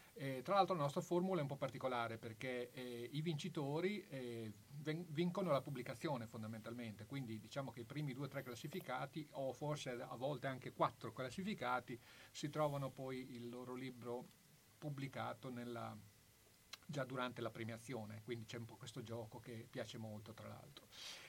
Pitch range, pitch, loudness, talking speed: 120-145 Hz, 125 Hz, -46 LUFS, 165 wpm